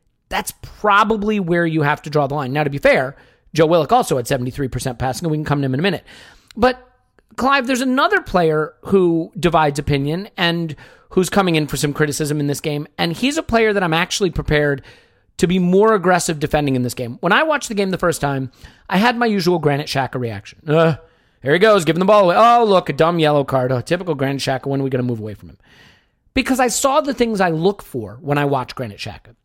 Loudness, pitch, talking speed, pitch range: -17 LUFS, 160 Hz, 240 wpm, 140-200 Hz